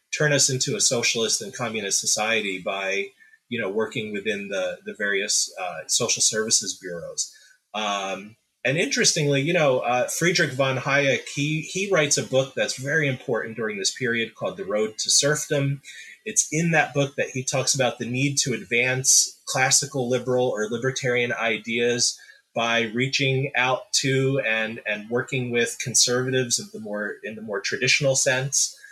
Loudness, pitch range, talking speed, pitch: -22 LUFS, 120-145 Hz, 165 wpm, 135 Hz